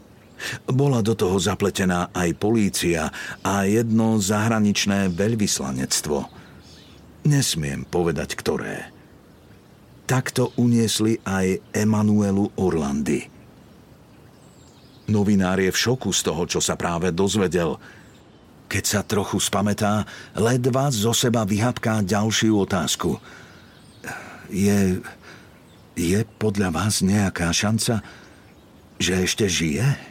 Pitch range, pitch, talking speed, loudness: 95-115 Hz, 105 Hz, 95 wpm, -22 LUFS